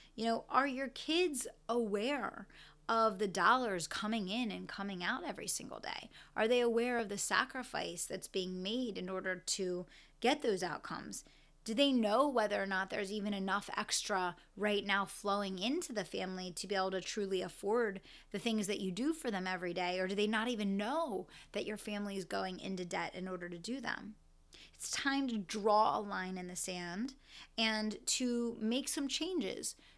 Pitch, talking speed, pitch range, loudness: 210 Hz, 190 wpm, 190-235 Hz, -37 LUFS